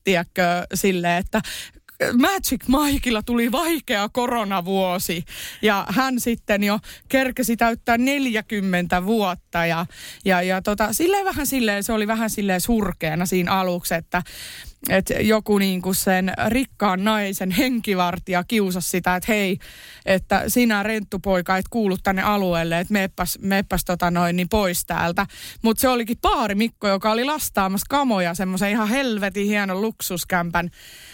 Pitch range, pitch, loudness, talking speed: 185-225 Hz, 200 Hz, -21 LUFS, 140 wpm